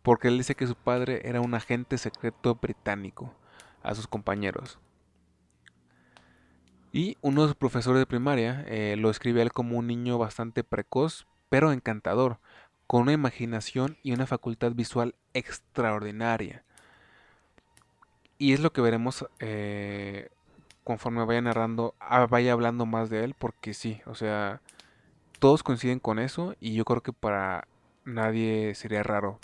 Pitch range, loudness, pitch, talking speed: 105-125 Hz, -28 LUFS, 115 Hz, 145 wpm